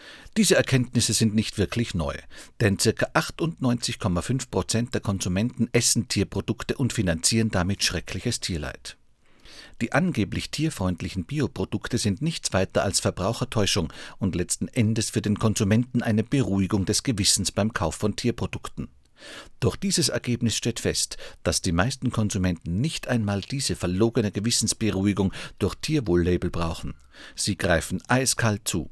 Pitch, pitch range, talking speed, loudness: 110 Hz, 95-120 Hz, 130 wpm, -25 LUFS